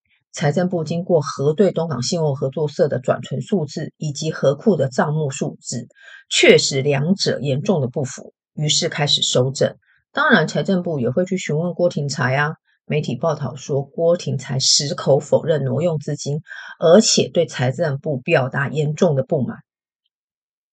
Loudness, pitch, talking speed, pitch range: -19 LUFS, 155 Hz, 250 characters per minute, 135-170 Hz